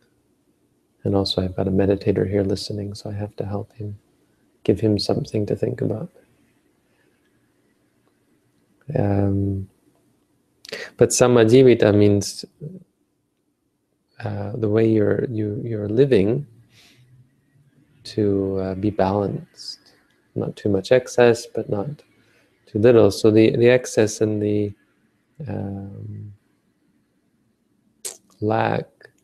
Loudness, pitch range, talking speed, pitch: -20 LUFS, 100-115 Hz, 110 wpm, 105 Hz